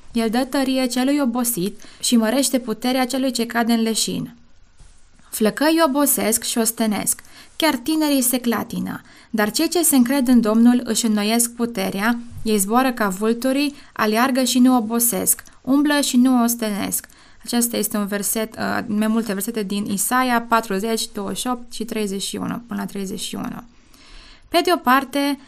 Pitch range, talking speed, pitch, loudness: 215-260 Hz, 150 wpm, 235 Hz, -19 LUFS